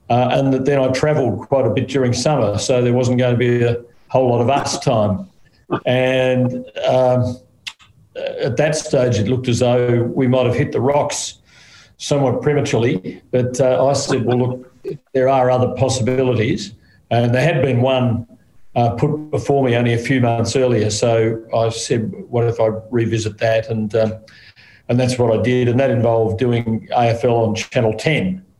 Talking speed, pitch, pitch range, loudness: 180 wpm, 125 Hz, 115-130 Hz, -17 LUFS